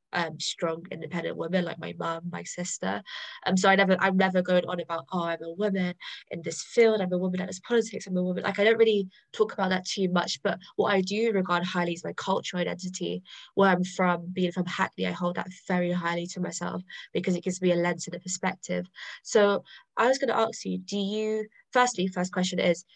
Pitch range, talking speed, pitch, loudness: 175-195 Hz, 235 wpm, 185 Hz, -28 LUFS